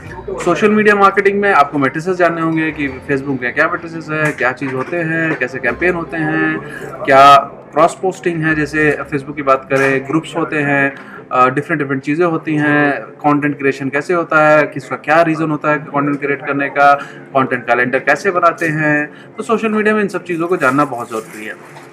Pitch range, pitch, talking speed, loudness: 140-165 Hz, 150 Hz, 190 wpm, -14 LUFS